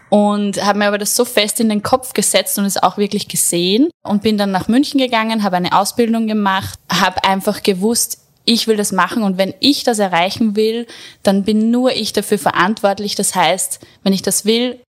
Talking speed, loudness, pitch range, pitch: 205 wpm, -15 LUFS, 195-225 Hz, 205 Hz